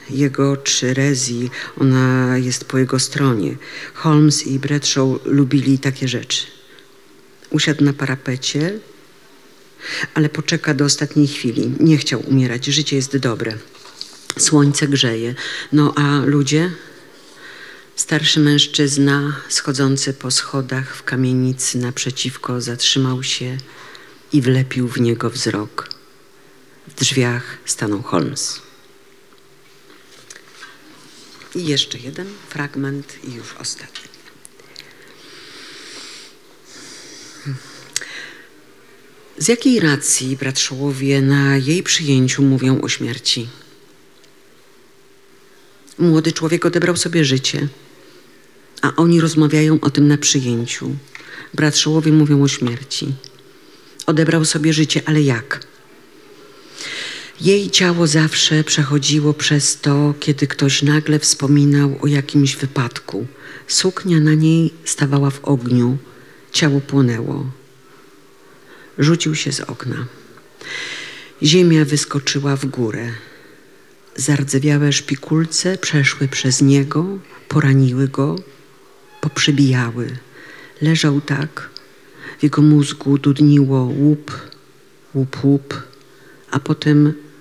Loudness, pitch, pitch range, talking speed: -16 LUFS, 145 Hz, 135-155 Hz, 95 wpm